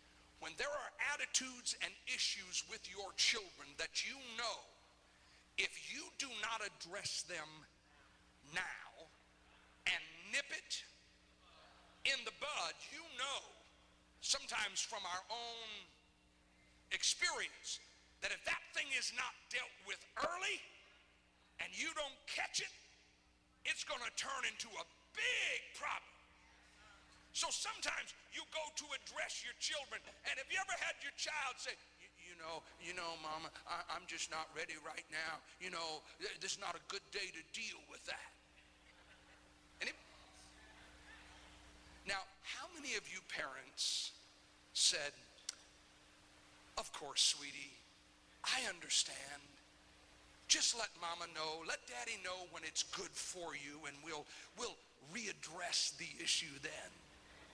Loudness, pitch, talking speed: -42 LUFS, 75 Hz, 135 wpm